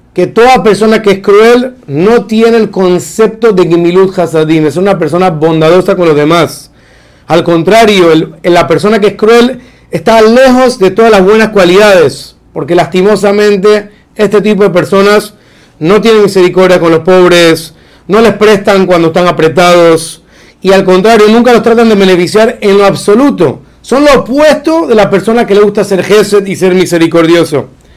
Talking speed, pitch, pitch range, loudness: 165 wpm, 195 Hz, 175-220 Hz, -5 LUFS